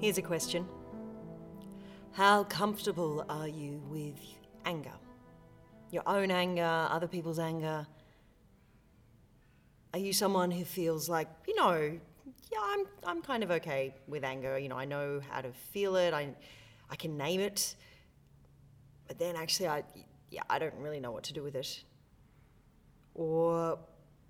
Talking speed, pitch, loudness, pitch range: 145 wpm, 160 Hz, -34 LUFS, 140-185 Hz